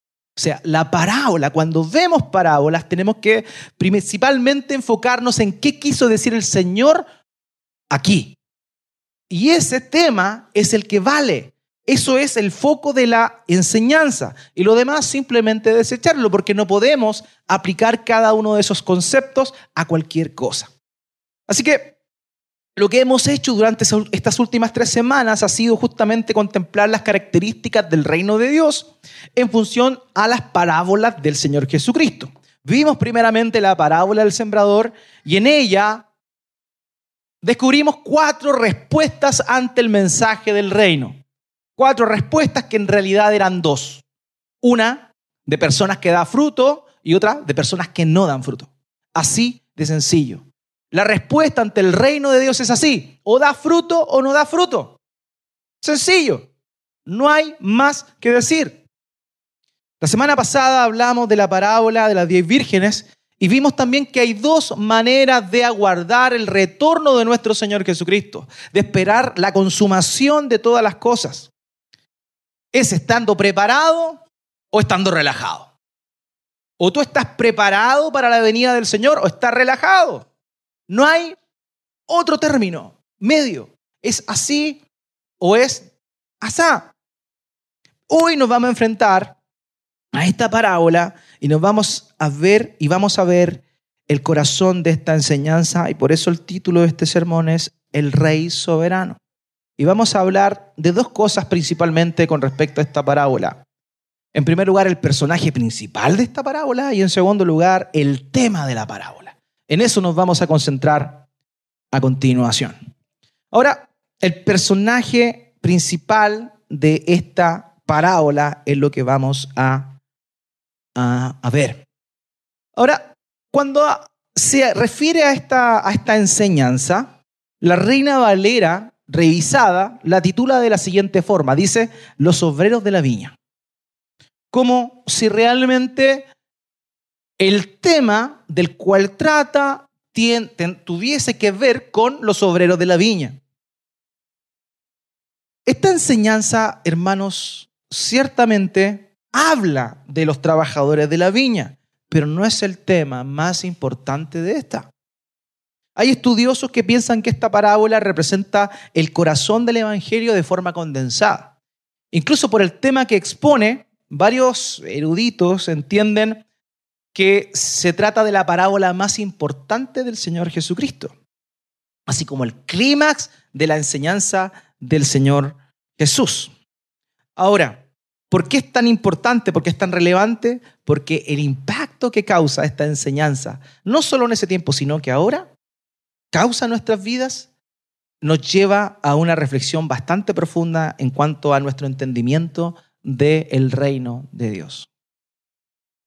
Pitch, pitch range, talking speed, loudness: 200 Hz, 160-245 Hz, 135 wpm, -16 LUFS